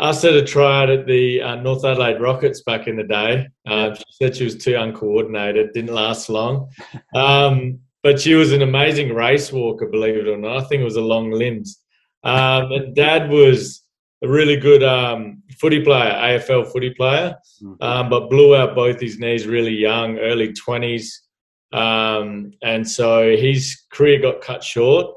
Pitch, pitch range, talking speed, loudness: 125 Hz, 115-140 Hz, 175 wpm, -16 LUFS